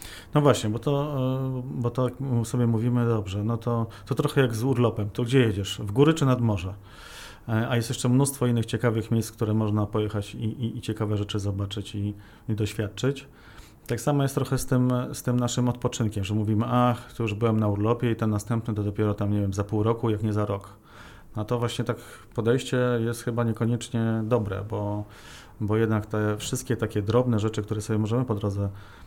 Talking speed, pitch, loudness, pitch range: 205 wpm, 115 Hz, -26 LUFS, 105-125 Hz